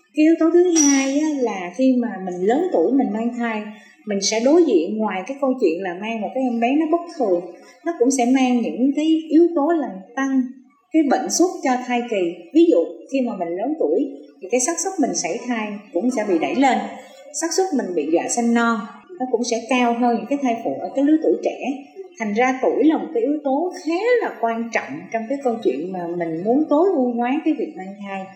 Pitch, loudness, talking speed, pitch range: 250 Hz, -20 LUFS, 240 wpm, 225-300 Hz